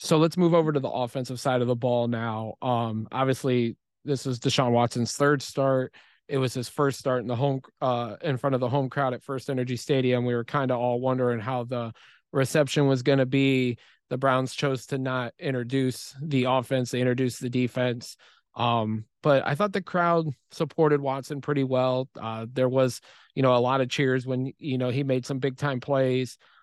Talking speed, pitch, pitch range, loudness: 205 wpm, 130 Hz, 125-140 Hz, -26 LUFS